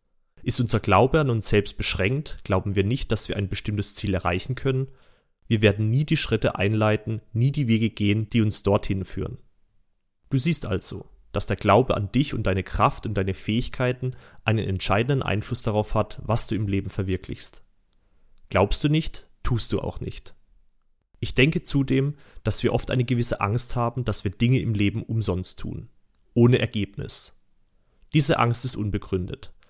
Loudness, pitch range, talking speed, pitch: -23 LUFS, 100-125 Hz, 170 wpm, 110 Hz